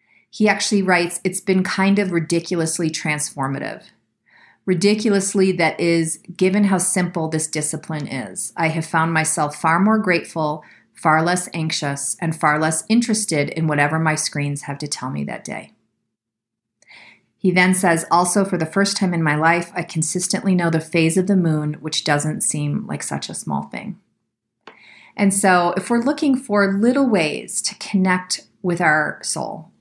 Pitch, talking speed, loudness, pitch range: 170 Hz, 165 wpm, -19 LUFS, 160-195 Hz